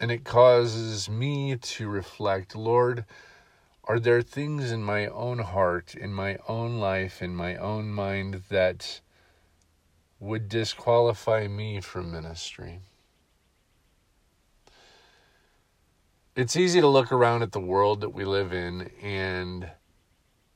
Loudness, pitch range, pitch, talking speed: -26 LUFS, 90-115 Hz, 100 Hz, 120 wpm